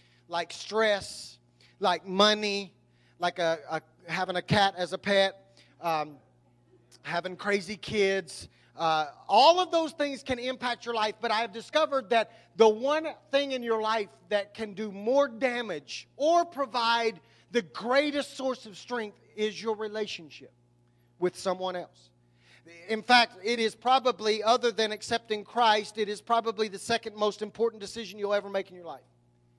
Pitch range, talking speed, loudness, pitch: 170-230 Hz, 160 wpm, -28 LUFS, 210 Hz